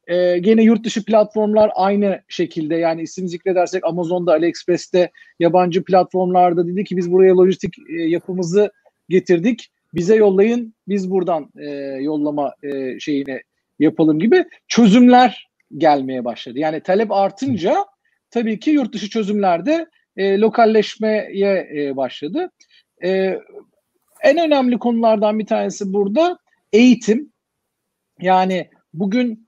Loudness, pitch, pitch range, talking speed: -17 LUFS, 195 Hz, 175-225 Hz, 110 wpm